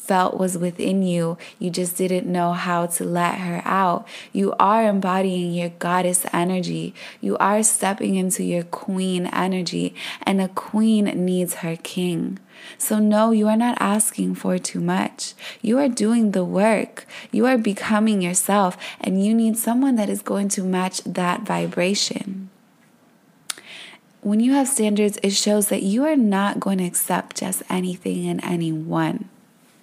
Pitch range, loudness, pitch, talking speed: 180-220 Hz, -21 LUFS, 195 Hz, 155 wpm